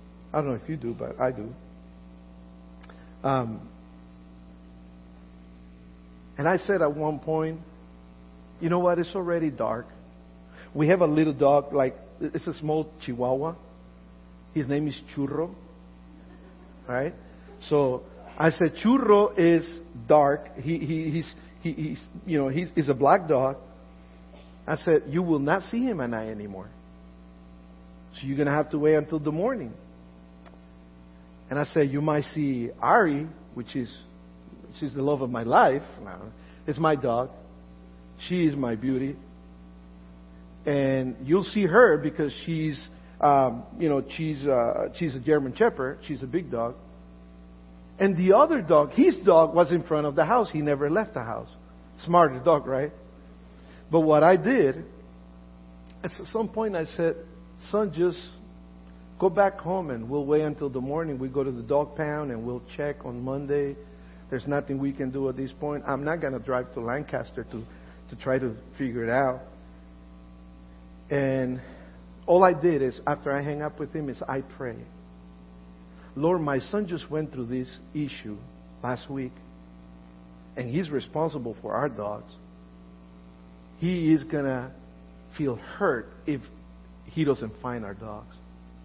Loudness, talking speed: -26 LUFS, 155 wpm